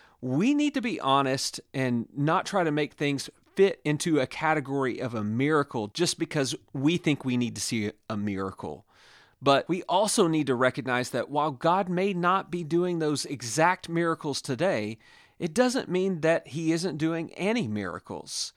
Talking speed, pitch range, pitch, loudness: 175 wpm, 130-175 Hz, 150 Hz, -27 LUFS